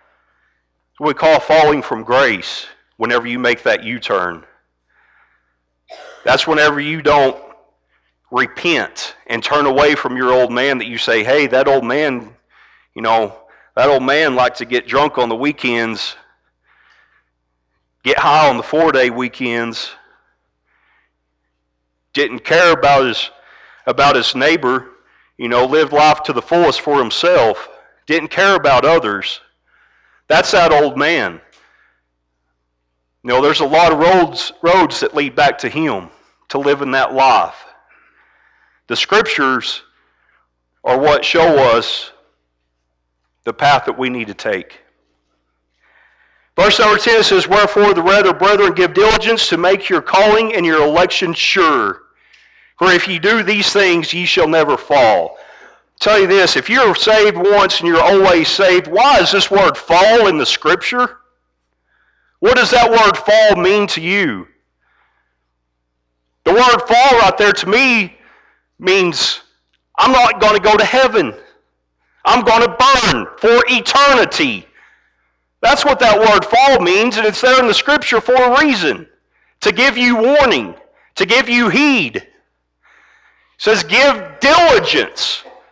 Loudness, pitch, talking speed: -12 LUFS, 170 Hz, 145 wpm